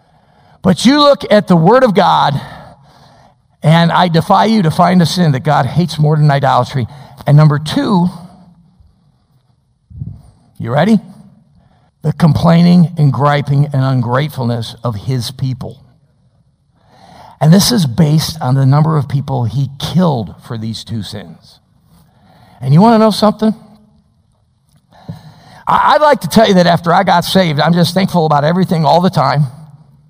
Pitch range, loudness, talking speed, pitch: 140-180 Hz, -11 LUFS, 150 wpm, 155 Hz